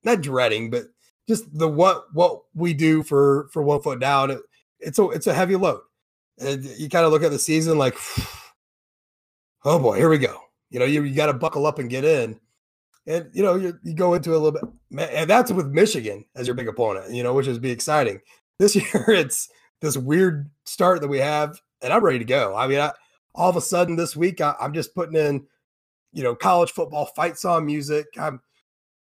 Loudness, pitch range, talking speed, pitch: -21 LUFS, 140-175 Hz, 220 wpm, 155 Hz